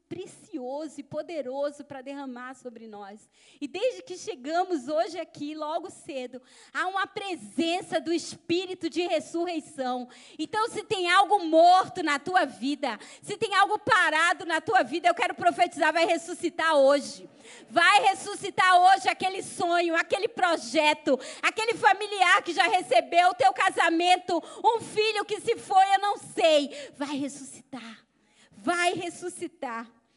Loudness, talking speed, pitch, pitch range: -25 LUFS, 140 wpm, 340 Hz, 290-380 Hz